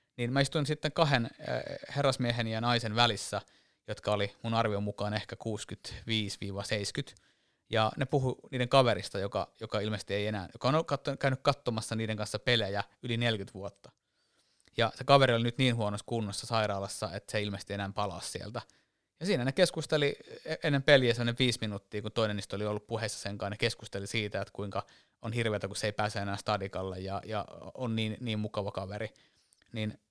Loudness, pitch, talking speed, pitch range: -32 LUFS, 110 Hz, 175 wpm, 100-120 Hz